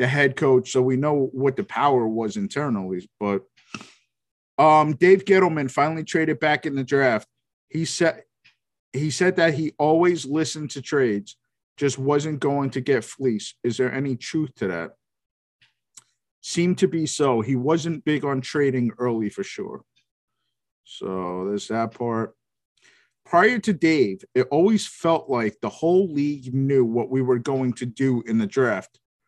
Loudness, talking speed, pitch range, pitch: -22 LUFS, 160 wpm, 125-155 Hz, 140 Hz